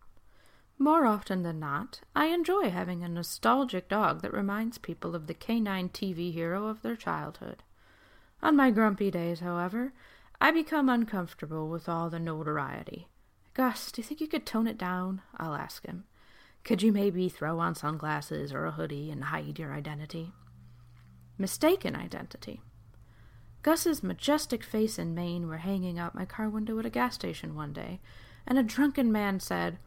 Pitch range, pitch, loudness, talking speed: 150-230 Hz, 180 Hz, -31 LUFS, 165 wpm